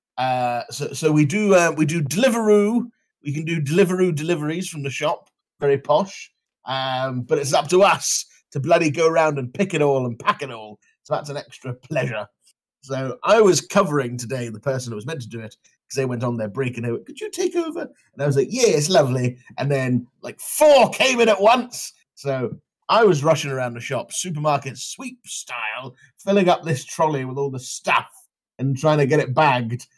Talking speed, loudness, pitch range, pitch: 215 wpm, -20 LUFS, 130-180 Hz, 145 Hz